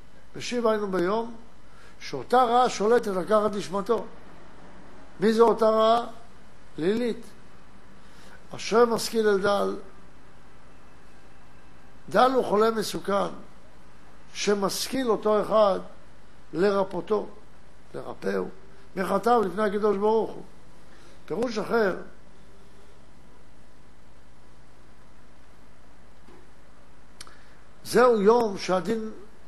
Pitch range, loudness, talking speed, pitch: 180-225 Hz, -25 LUFS, 70 wpm, 210 Hz